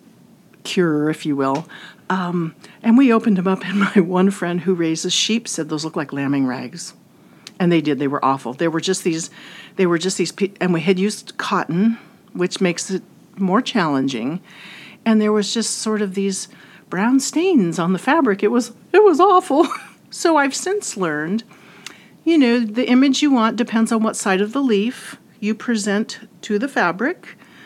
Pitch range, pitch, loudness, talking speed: 175-230 Hz, 200 Hz, -19 LUFS, 190 wpm